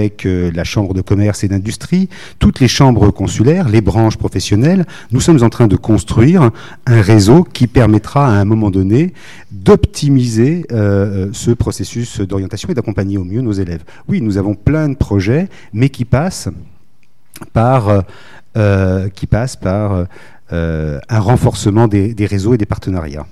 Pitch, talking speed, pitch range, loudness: 110 Hz, 160 wpm, 100-125 Hz, -13 LUFS